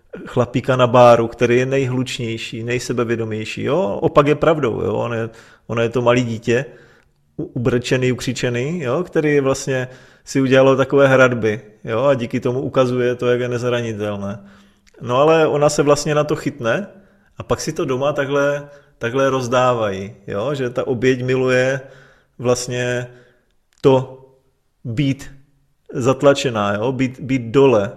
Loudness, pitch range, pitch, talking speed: -18 LUFS, 120-140 Hz, 130 Hz, 140 wpm